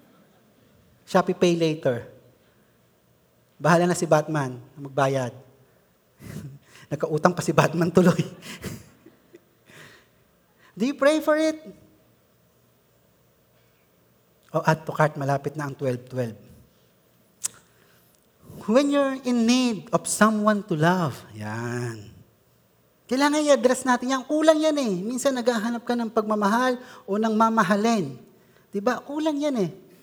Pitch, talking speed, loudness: 180 Hz, 110 wpm, -23 LUFS